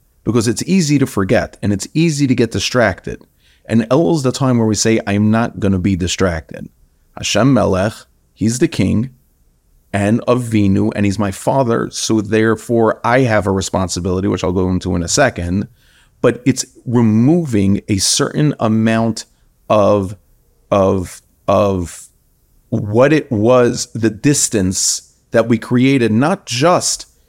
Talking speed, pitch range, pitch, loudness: 150 wpm, 95-125 Hz, 110 Hz, -15 LUFS